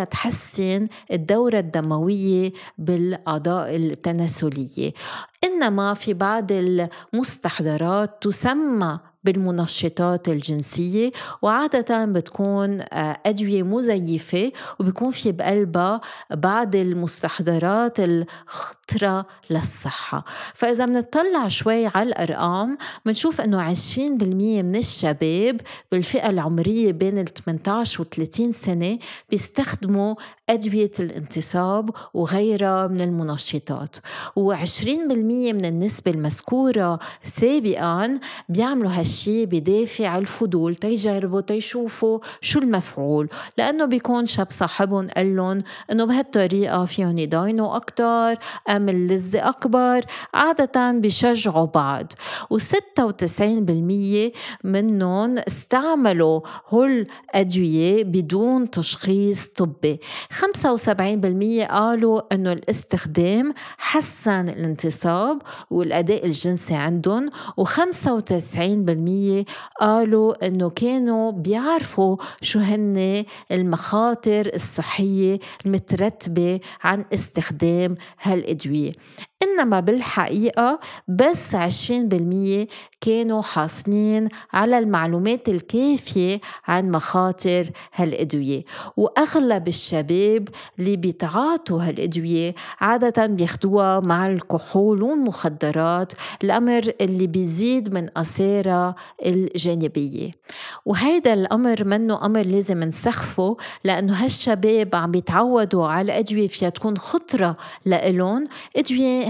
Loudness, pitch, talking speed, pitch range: -21 LUFS, 195 Hz, 85 wpm, 175-225 Hz